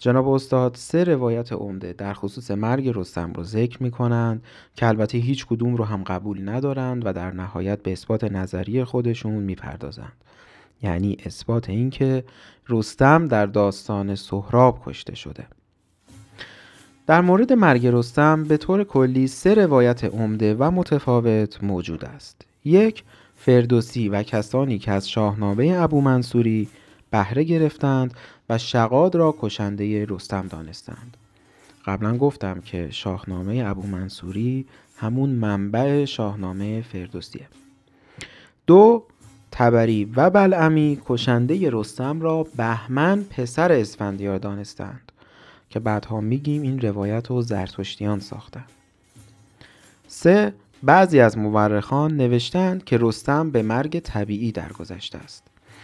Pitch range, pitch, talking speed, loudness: 100-135 Hz, 115 Hz, 120 wpm, -21 LUFS